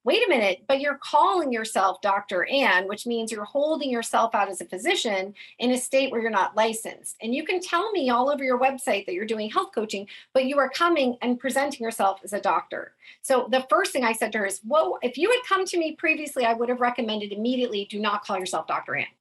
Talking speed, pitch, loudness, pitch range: 240 wpm, 245 Hz, -24 LUFS, 215-285 Hz